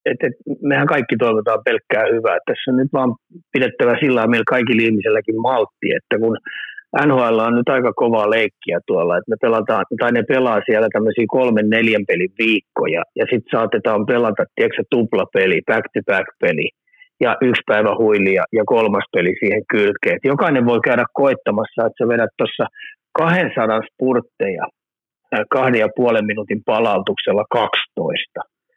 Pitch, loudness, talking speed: 130 Hz, -17 LUFS, 155 wpm